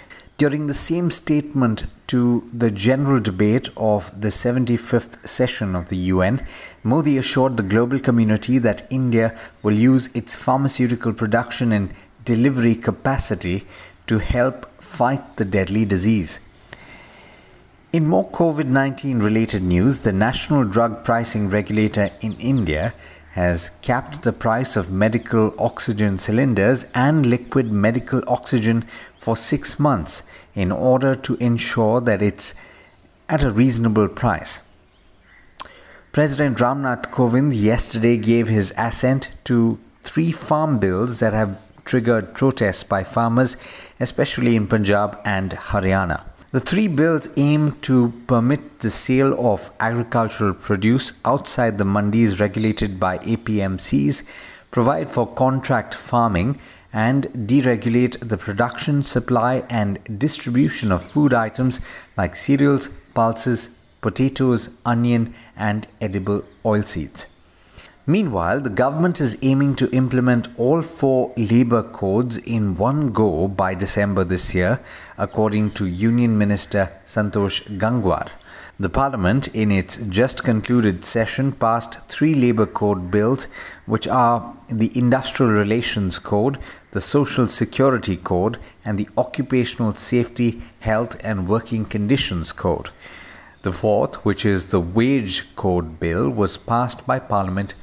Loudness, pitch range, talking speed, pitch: -19 LUFS, 105-130 Hz, 125 wpm, 115 Hz